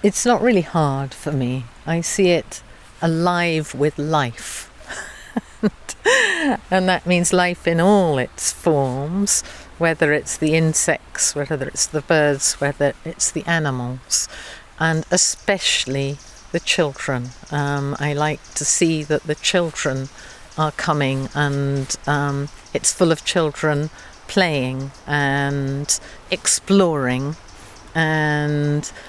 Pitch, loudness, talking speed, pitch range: 150 Hz, -19 LUFS, 115 wpm, 140-170 Hz